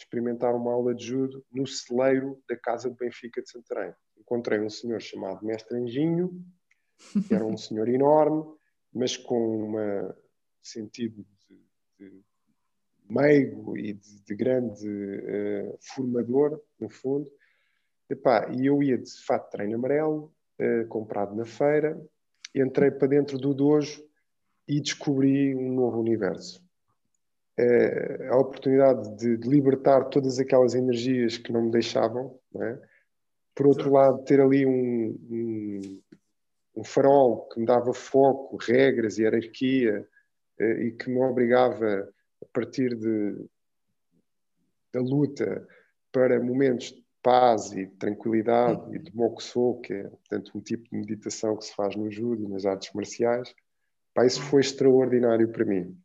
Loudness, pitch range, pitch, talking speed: -26 LUFS, 110-135 Hz, 125 Hz, 140 wpm